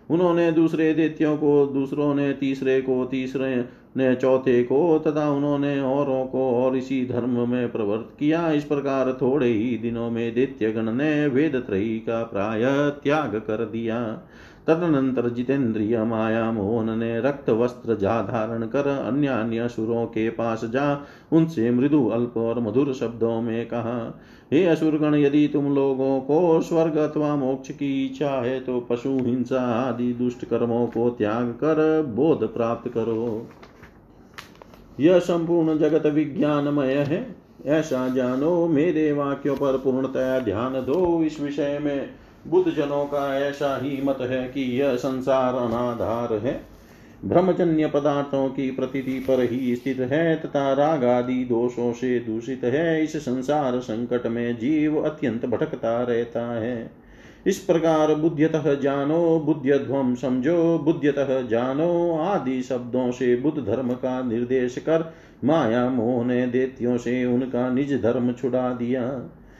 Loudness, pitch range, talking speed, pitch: -23 LUFS, 120-145 Hz, 130 wpm, 130 Hz